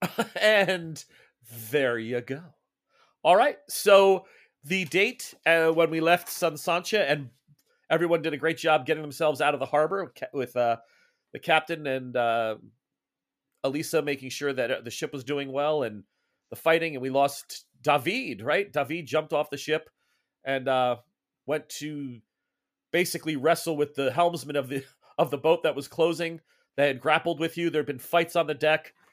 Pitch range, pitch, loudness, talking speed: 135-165 Hz, 155 Hz, -26 LUFS, 175 wpm